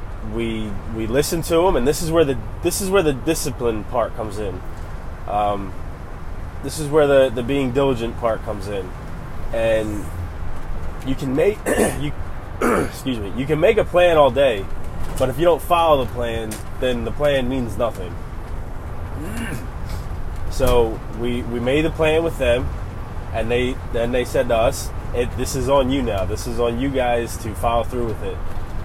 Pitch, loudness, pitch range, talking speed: 115 Hz, -21 LUFS, 95-130 Hz, 175 wpm